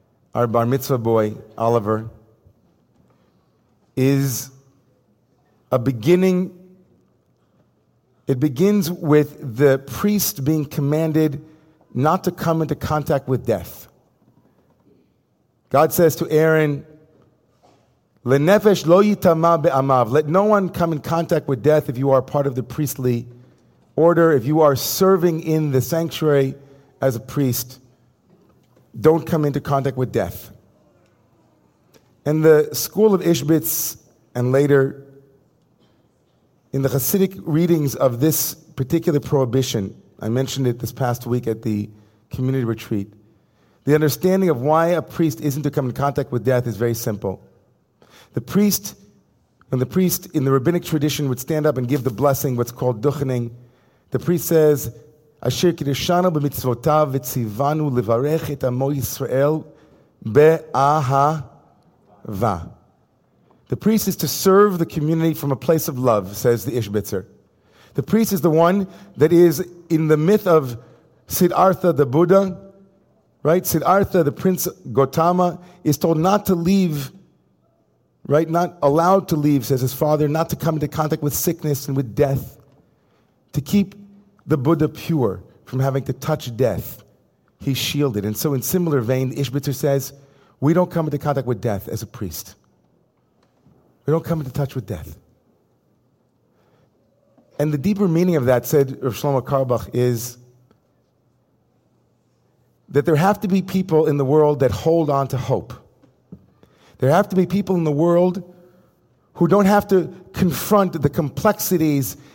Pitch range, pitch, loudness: 130-165 Hz, 145 Hz, -19 LUFS